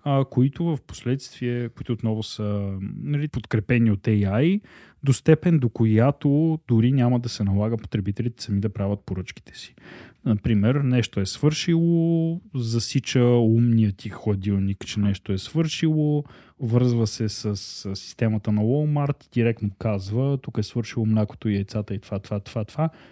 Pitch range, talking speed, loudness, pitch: 105-140 Hz, 145 wpm, -24 LUFS, 115 Hz